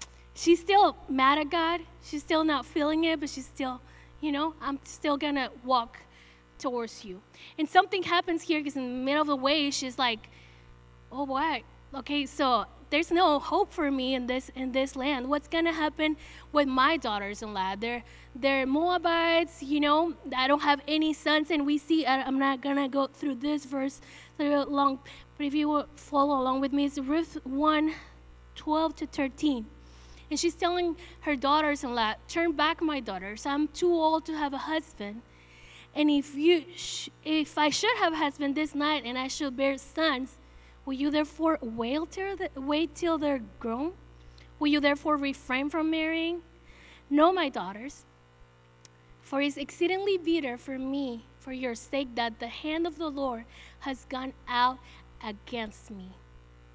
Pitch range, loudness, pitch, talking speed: 255-310 Hz, -28 LUFS, 285 Hz, 170 wpm